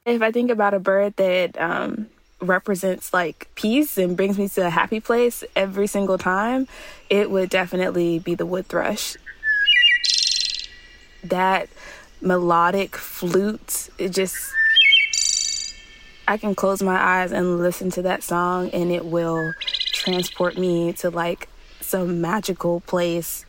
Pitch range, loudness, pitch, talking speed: 180-220 Hz, -20 LUFS, 190 Hz, 135 wpm